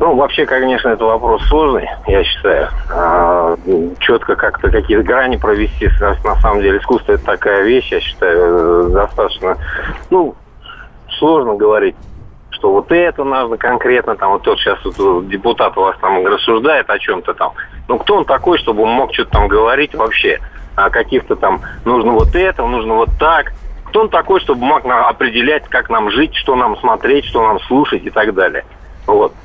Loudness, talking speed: -13 LUFS, 175 wpm